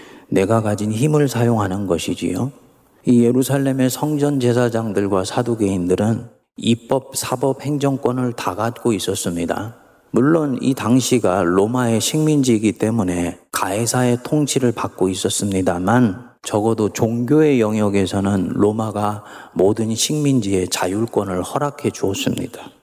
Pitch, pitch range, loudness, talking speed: 115 Hz, 100-130 Hz, -18 LUFS, 295 characters per minute